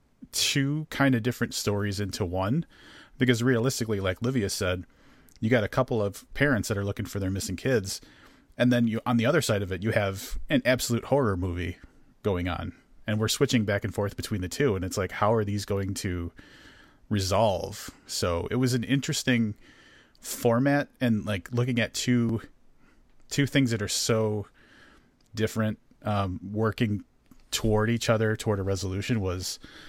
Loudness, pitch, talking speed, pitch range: -27 LUFS, 110 Hz, 175 wpm, 100-125 Hz